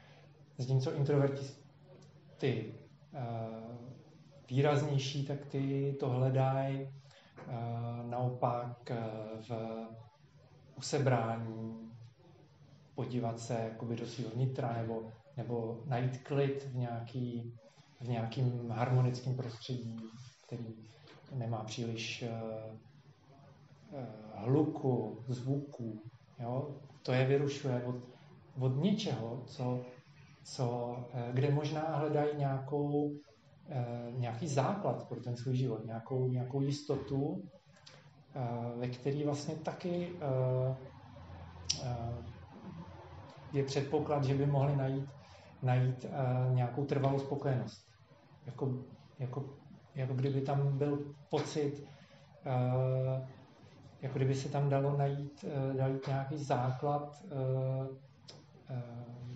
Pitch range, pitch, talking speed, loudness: 120-145 Hz, 130 Hz, 85 wpm, -36 LUFS